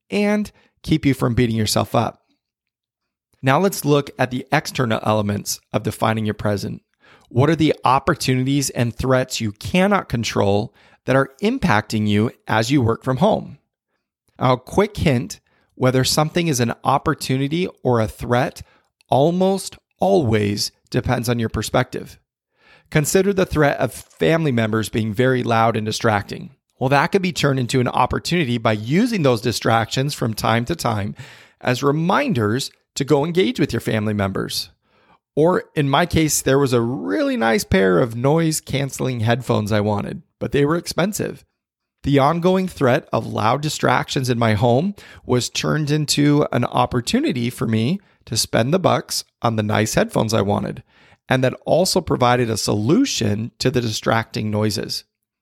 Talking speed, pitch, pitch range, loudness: 160 wpm, 125 Hz, 110-150 Hz, -19 LUFS